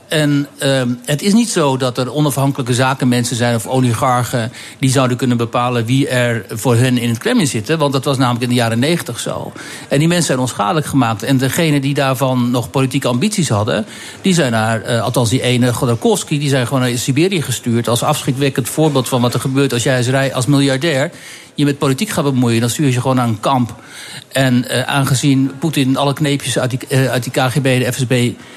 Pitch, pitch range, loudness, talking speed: 130 Hz, 125-140 Hz, -15 LUFS, 210 wpm